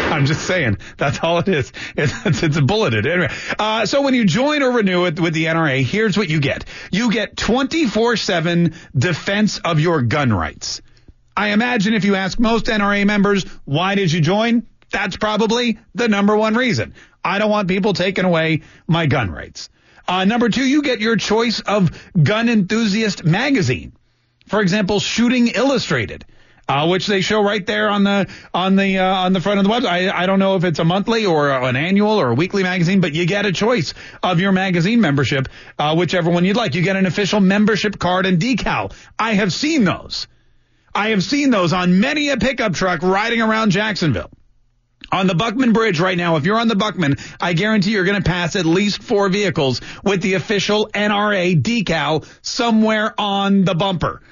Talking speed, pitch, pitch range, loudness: 195 wpm, 195 Hz, 175-215 Hz, -17 LUFS